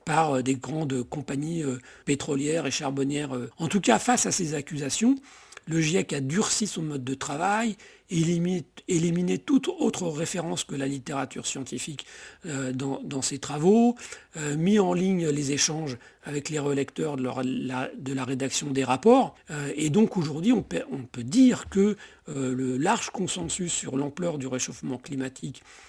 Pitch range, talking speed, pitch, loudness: 135-180 Hz, 155 wpm, 150 Hz, -27 LUFS